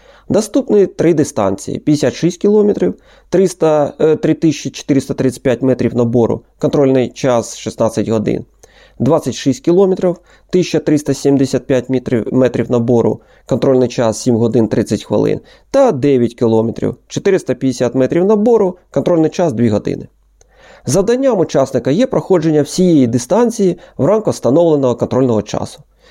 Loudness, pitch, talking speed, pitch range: -14 LUFS, 140 Hz, 105 wpm, 120-175 Hz